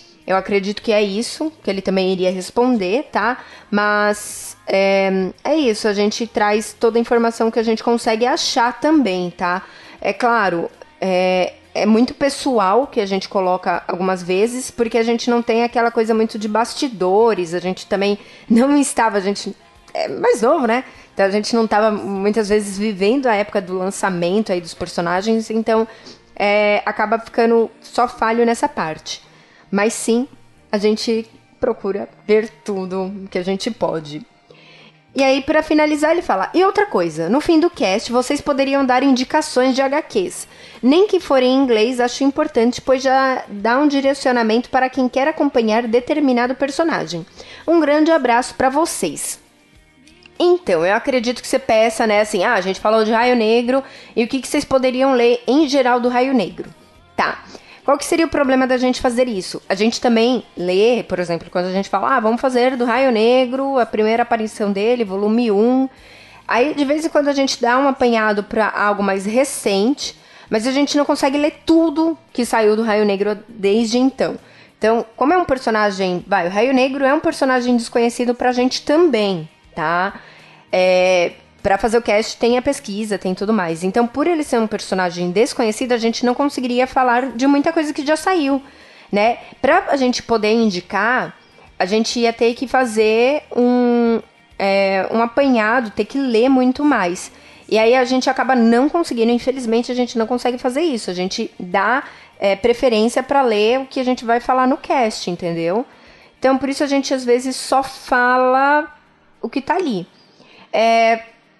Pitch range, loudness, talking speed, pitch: 210-265 Hz, -17 LUFS, 180 wpm, 235 Hz